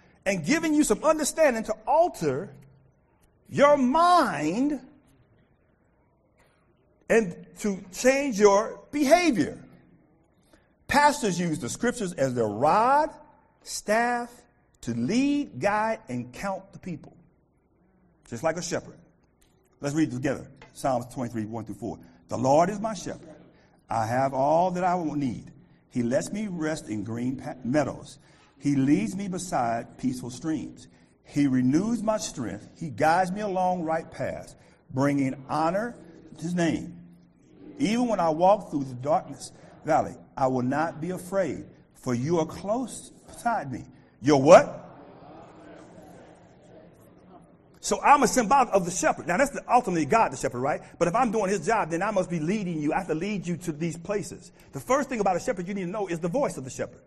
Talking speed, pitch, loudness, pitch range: 165 wpm, 180 Hz, -26 LUFS, 150-225 Hz